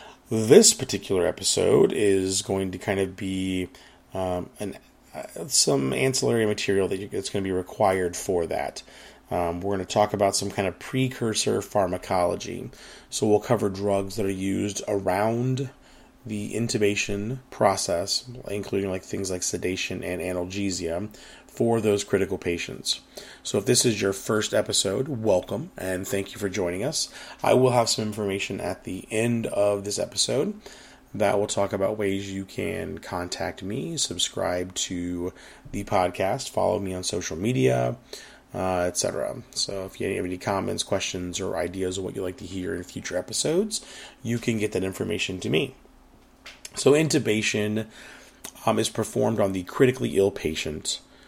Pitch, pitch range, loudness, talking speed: 100 Hz, 90-105 Hz, -25 LUFS, 160 wpm